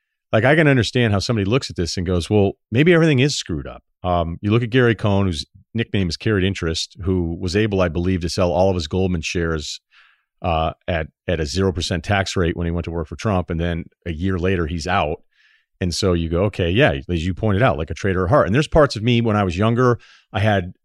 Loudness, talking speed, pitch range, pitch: -20 LUFS, 255 wpm, 85-110 Hz, 95 Hz